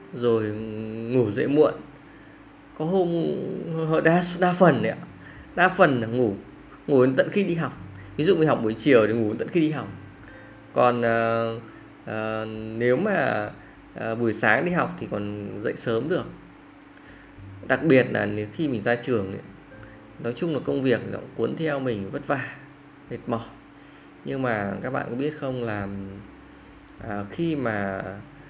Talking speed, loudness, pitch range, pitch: 170 wpm, -24 LUFS, 105-145 Hz, 115 Hz